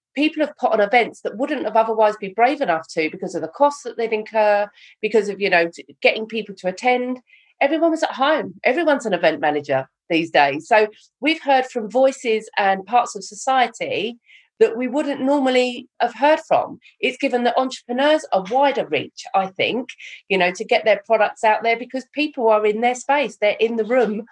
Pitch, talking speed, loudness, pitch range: 235 Hz, 200 wpm, -20 LUFS, 205-275 Hz